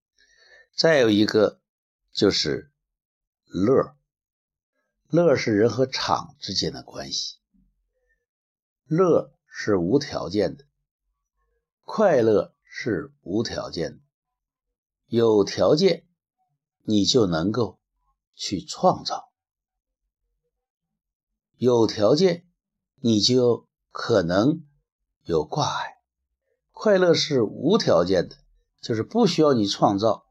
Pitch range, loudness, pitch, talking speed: 115-185 Hz, -22 LUFS, 145 Hz, 130 characters per minute